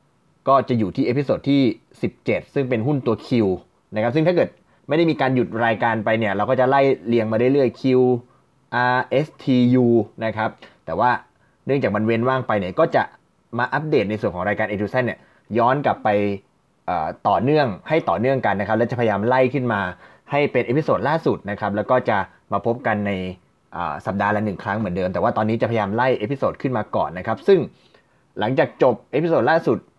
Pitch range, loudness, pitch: 105-130 Hz, -21 LUFS, 115 Hz